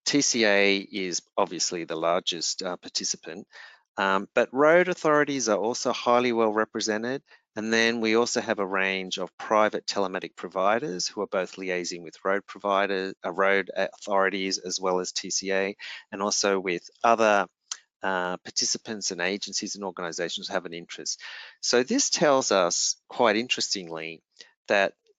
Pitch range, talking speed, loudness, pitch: 95-120 Hz, 150 wpm, -26 LUFS, 100 Hz